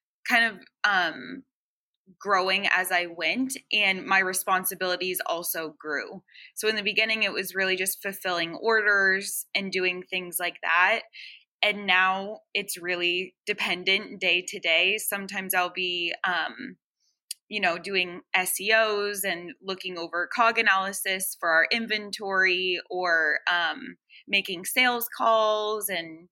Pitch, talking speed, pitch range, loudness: 190 Hz, 130 wpm, 180-210 Hz, -25 LUFS